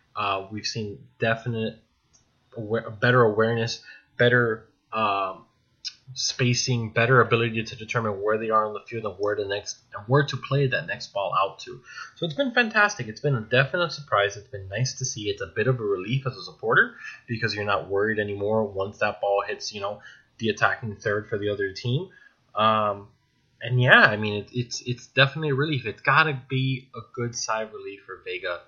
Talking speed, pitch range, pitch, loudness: 195 wpm, 105-135 Hz, 120 Hz, -24 LUFS